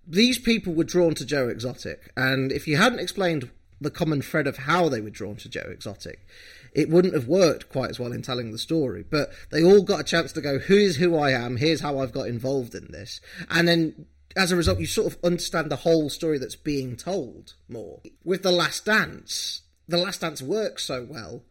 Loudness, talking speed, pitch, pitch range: -24 LUFS, 225 wpm, 155 Hz, 130-175 Hz